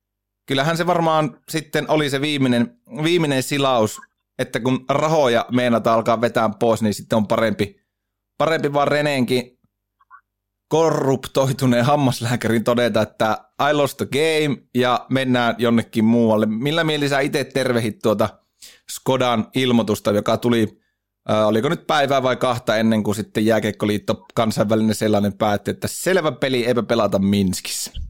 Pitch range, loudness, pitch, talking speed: 110-140 Hz, -19 LUFS, 120 Hz, 130 wpm